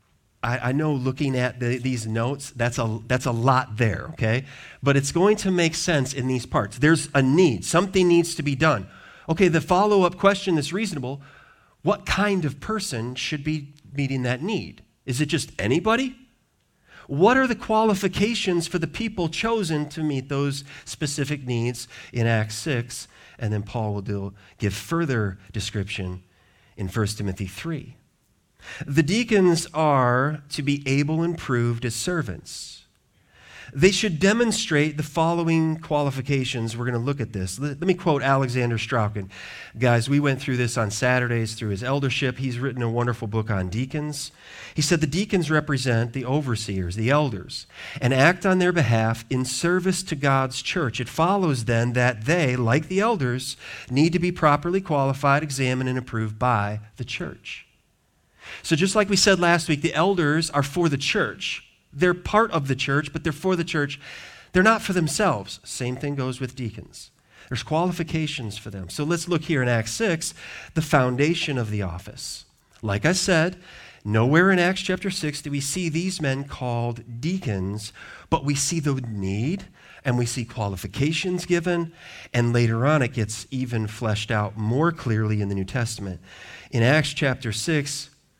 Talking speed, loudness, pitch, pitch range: 170 wpm, -23 LUFS, 140 Hz, 120-165 Hz